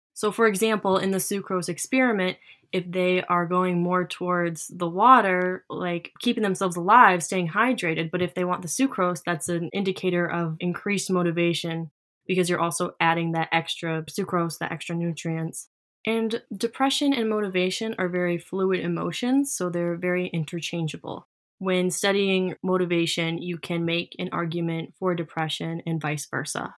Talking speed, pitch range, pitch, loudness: 150 wpm, 170-190 Hz, 180 Hz, -25 LUFS